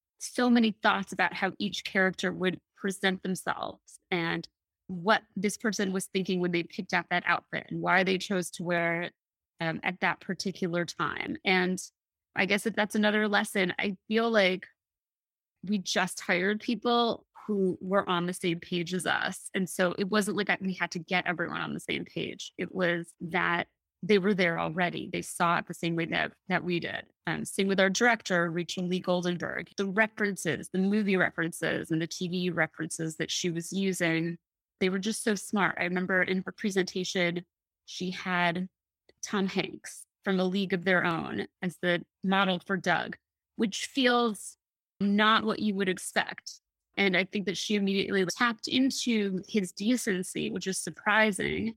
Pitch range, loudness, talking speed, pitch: 175-205 Hz, -29 LUFS, 175 wpm, 185 Hz